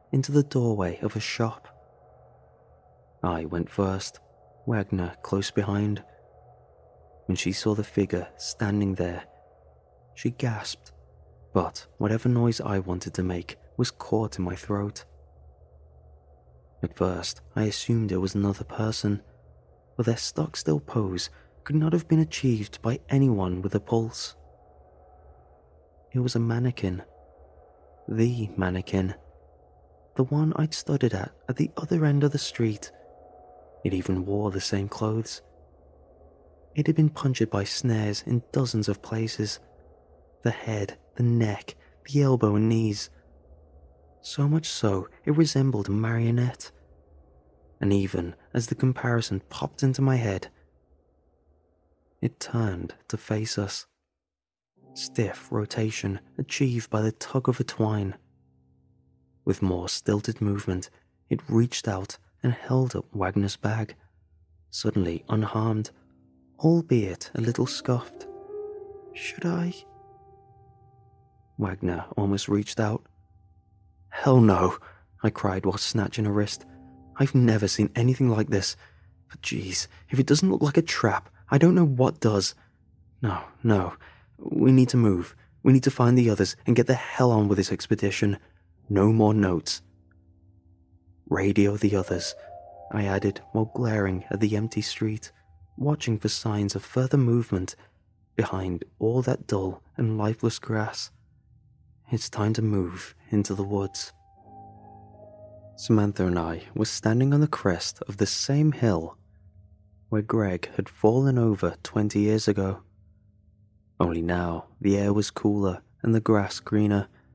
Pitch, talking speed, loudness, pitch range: 100 Hz, 135 wpm, -26 LUFS, 90-115 Hz